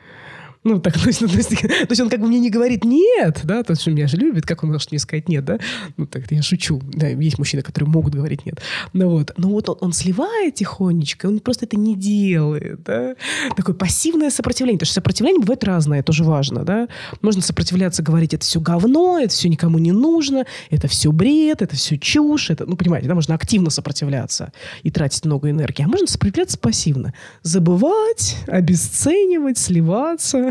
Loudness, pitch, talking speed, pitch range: -18 LUFS, 180 Hz, 195 wpm, 155-240 Hz